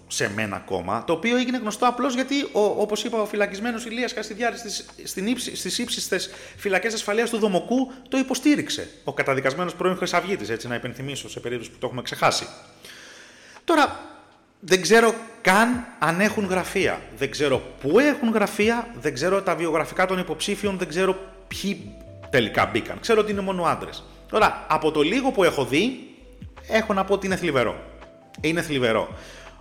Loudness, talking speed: -23 LUFS, 160 wpm